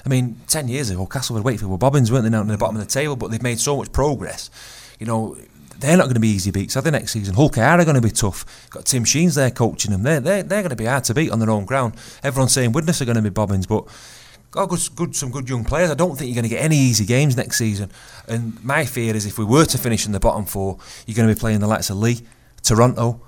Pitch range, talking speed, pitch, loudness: 110-140 Hz, 295 wpm, 120 Hz, -19 LUFS